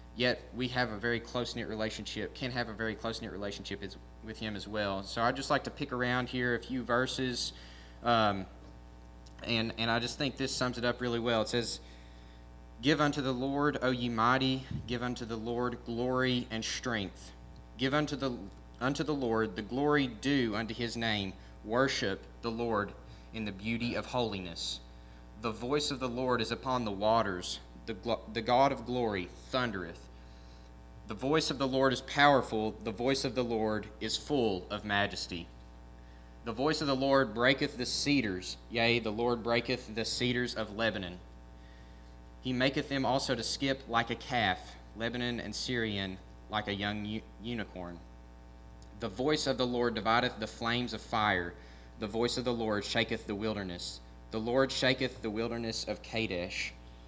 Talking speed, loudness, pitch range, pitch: 170 wpm, -33 LUFS, 90-125 Hz, 115 Hz